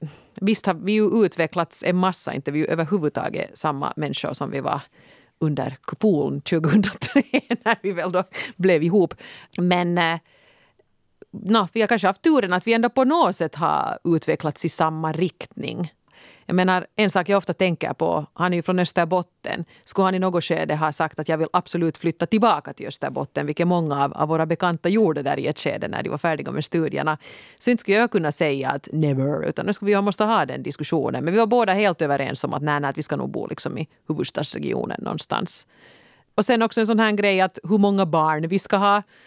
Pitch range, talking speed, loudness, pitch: 160-205 Hz, 205 wpm, -22 LUFS, 180 Hz